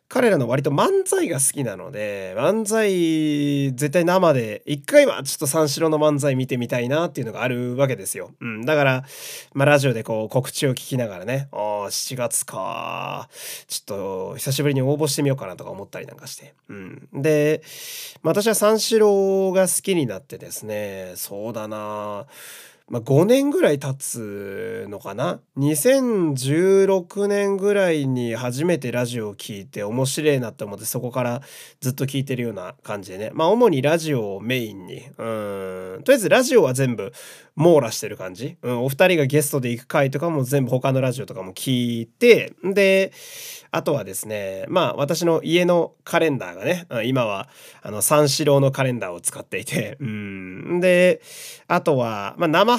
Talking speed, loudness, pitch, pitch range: 330 characters per minute, -21 LUFS, 140 Hz, 120-175 Hz